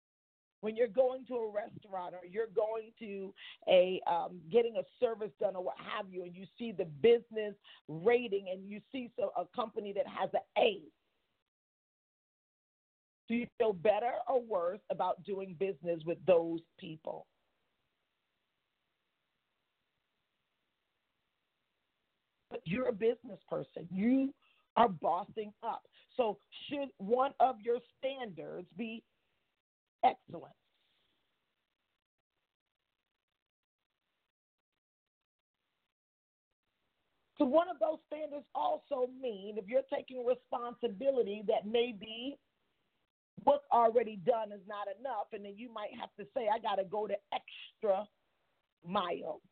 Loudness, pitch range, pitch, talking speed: -35 LUFS, 200-255 Hz, 225 Hz, 120 wpm